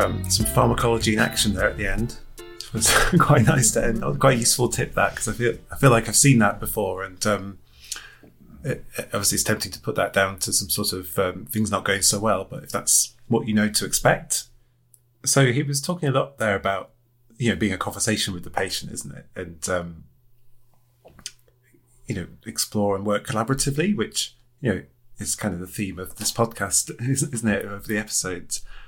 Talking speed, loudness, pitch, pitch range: 210 wpm, -22 LUFS, 110 Hz, 100-120 Hz